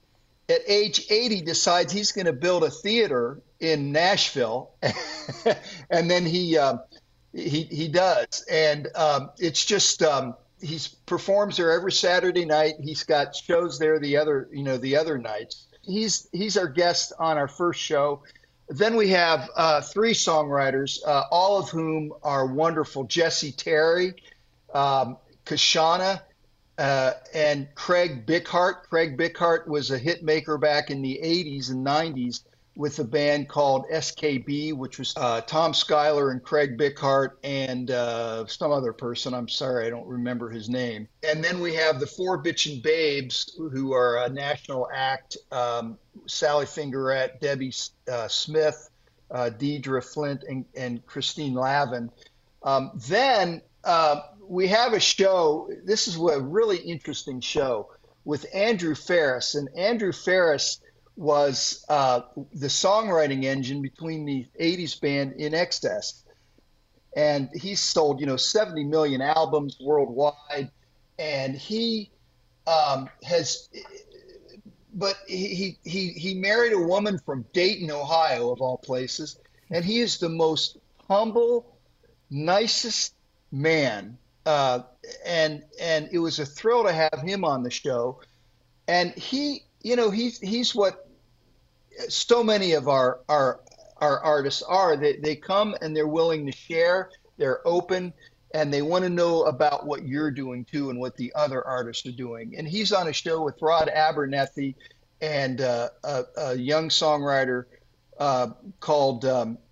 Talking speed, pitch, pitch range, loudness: 145 wpm, 155 Hz, 135-180 Hz, -25 LUFS